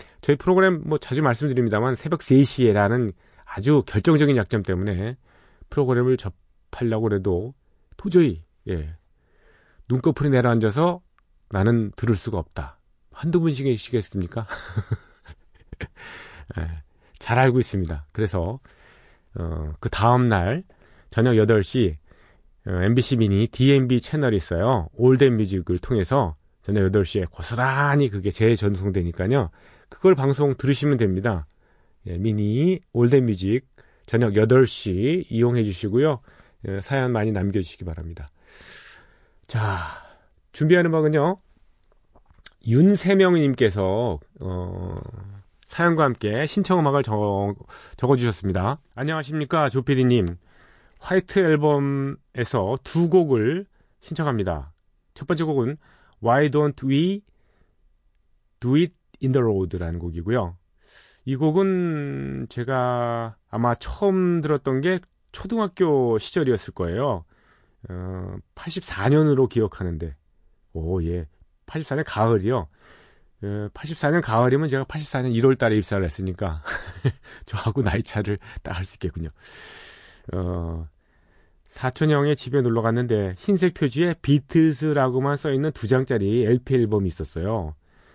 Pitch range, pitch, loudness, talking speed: 95-140 Hz, 115 Hz, -22 LUFS, 260 characters per minute